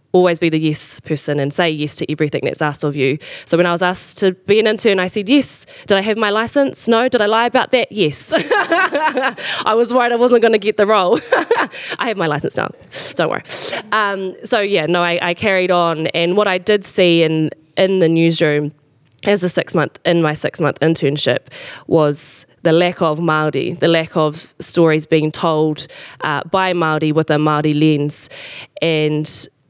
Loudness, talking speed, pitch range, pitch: -15 LUFS, 200 wpm, 155-205 Hz, 170 Hz